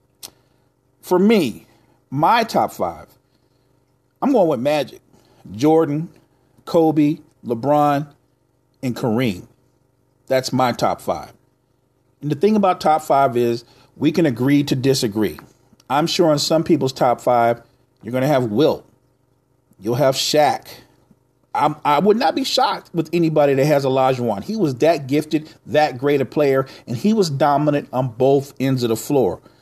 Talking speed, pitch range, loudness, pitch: 150 wpm, 130-150 Hz, -18 LUFS, 135 Hz